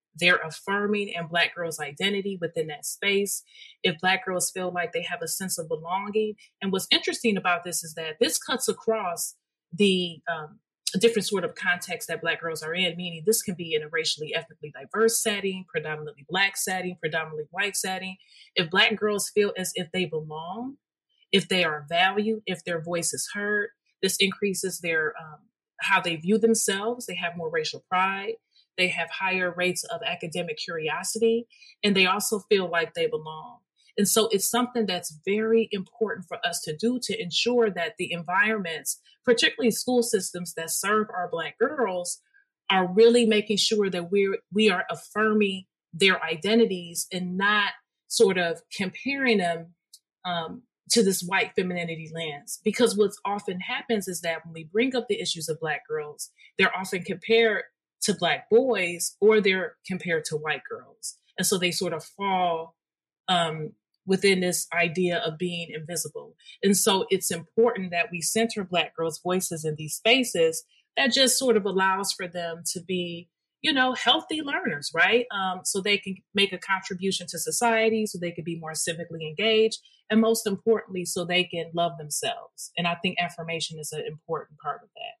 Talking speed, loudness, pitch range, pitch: 175 wpm, -25 LUFS, 170-220 Hz, 190 Hz